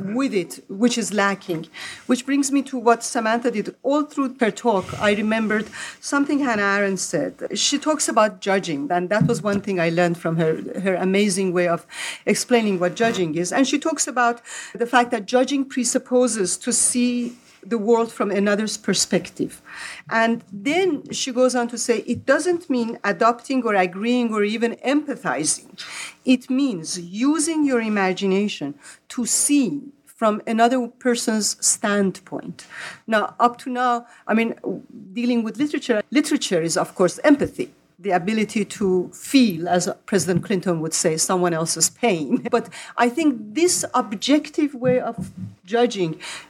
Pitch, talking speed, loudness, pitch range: 230 Hz, 155 wpm, -21 LUFS, 195-255 Hz